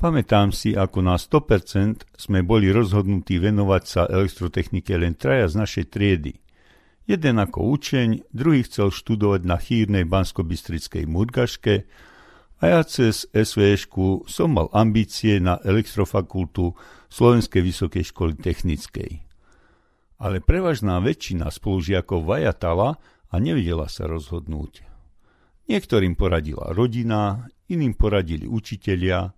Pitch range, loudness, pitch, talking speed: 90-110 Hz, -22 LUFS, 100 Hz, 110 wpm